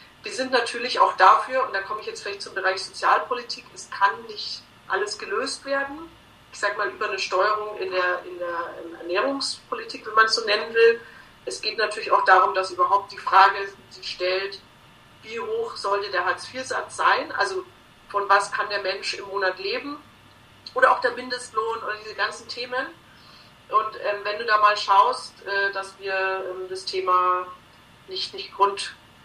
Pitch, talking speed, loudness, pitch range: 210 Hz, 180 wpm, -23 LUFS, 190-260 Hz